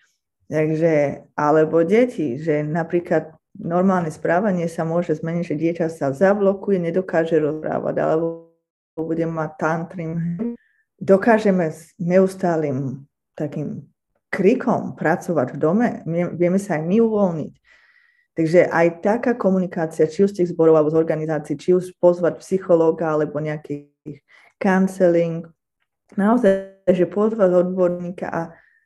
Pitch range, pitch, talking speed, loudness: 160-190 Hz, 170 Hz, 120 wpm, -20 LUFS